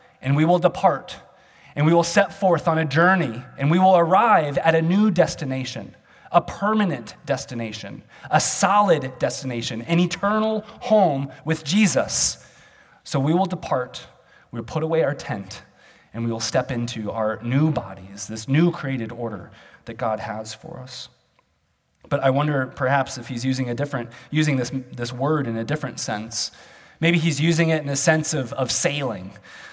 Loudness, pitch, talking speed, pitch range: -21 LUFS, 140 Hz, 170 wpm, 120-170 Hz